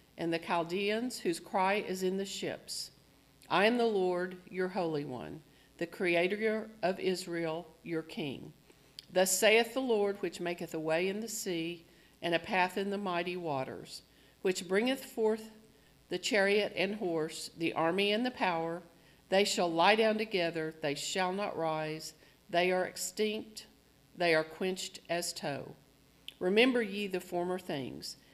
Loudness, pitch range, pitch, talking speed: -33 LUFS, 165-200 Hz, 180 Hz, 155 wpm